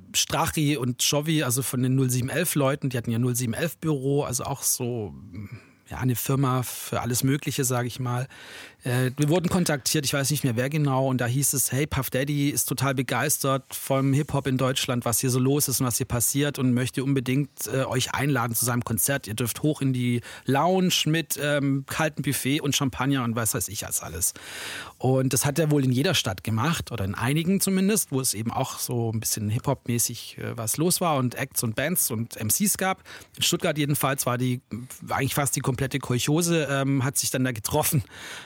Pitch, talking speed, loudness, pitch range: 135 Hz, 205 wpm, -25 LUFS, 125-145 Hz